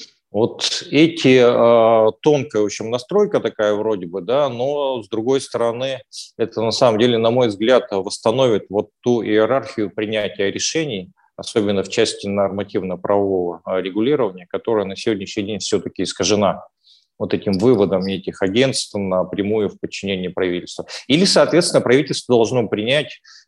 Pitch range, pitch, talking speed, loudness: 100-125 Hz, 110 Hz, 135 wpm, -18 LUFS